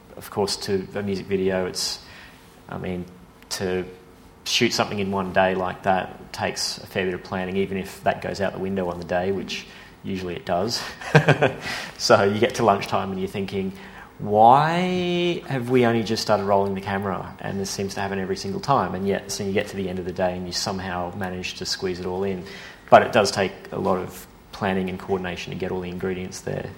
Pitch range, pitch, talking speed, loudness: 90-115 Hz, 95 Hz, 220 wpm, -23 LUFS